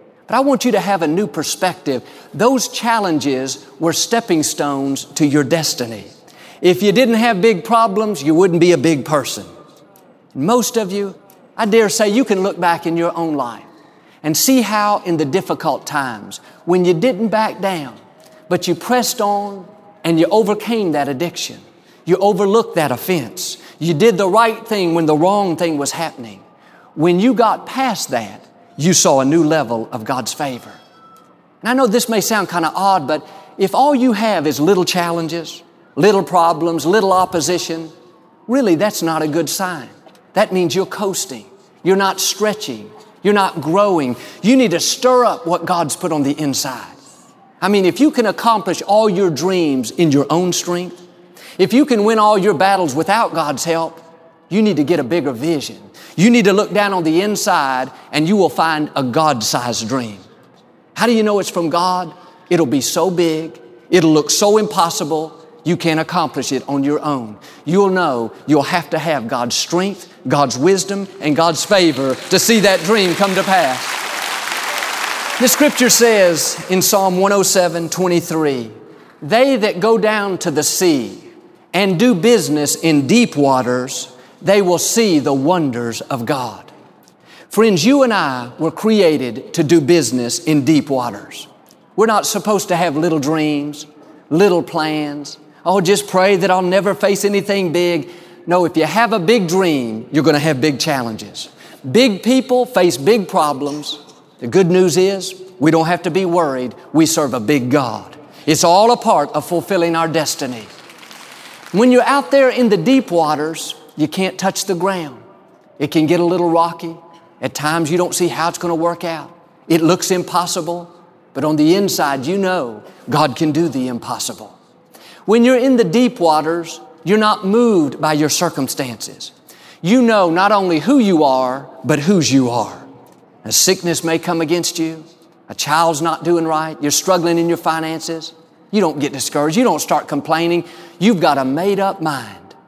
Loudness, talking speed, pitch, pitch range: -15 LUFS, 175 wpm, 175 Hz, 155-200 Hz